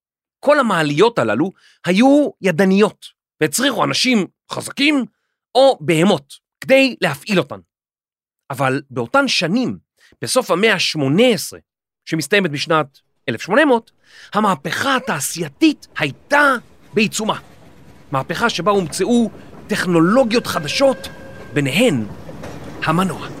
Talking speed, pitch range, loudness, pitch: 85 wpm, 155-250 Hz, -17 LUFS, 200 Hz